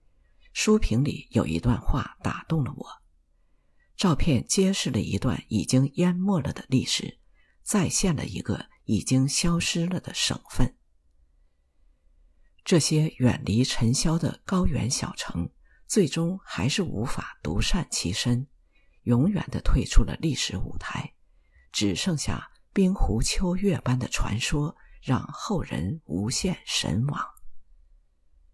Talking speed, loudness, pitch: 185 characters per minute, -26 LUFS, 120 Hz